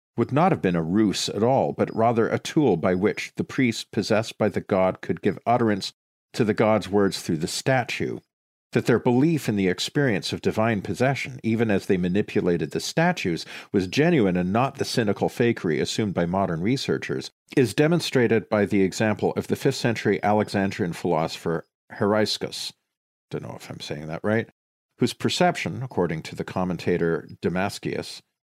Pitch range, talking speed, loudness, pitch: 95-120 Hz, 170 wpm, -24 LUFS, 105 Hz